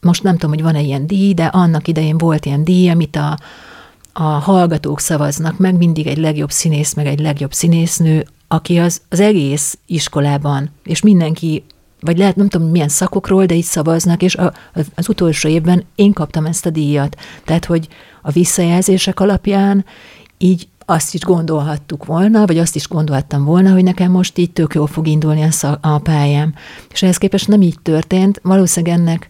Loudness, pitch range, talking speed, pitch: -14 LUFS, 155-185 Hz, 175 wpm, 165 Hz